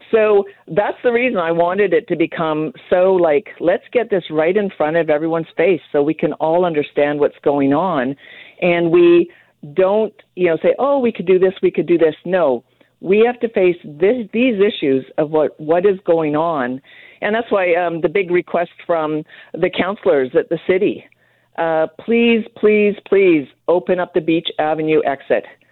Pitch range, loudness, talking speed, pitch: 160-205 Hz, -17 LUFS, 185 wpm, 175 Hz